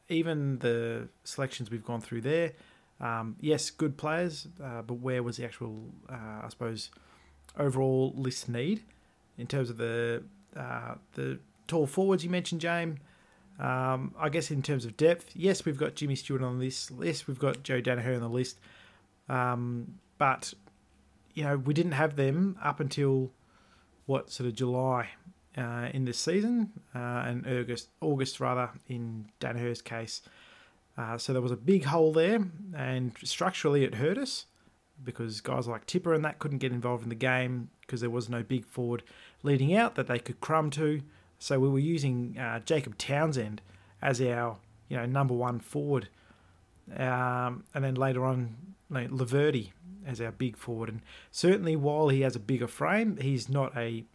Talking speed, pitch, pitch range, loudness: 170 wpm, 130 Hz, 120-150 Hz, -31 LUFS